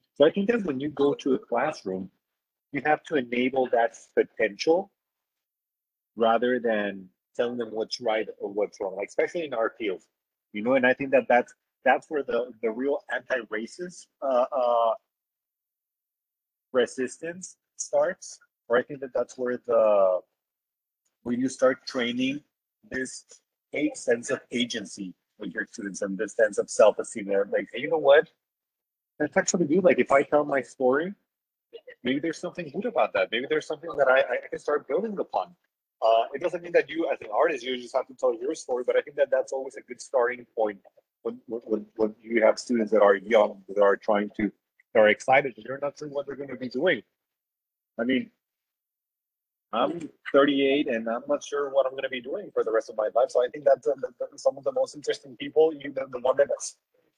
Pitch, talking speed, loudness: 140 Hz, 200 wpm, -26 LUFS